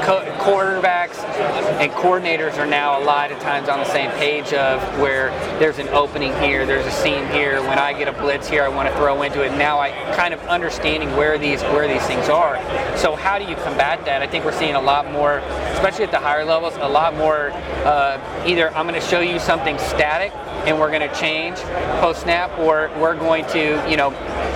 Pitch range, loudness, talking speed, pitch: 140-160 Hz, -19 LUFS, 220 wpm, 145 Hz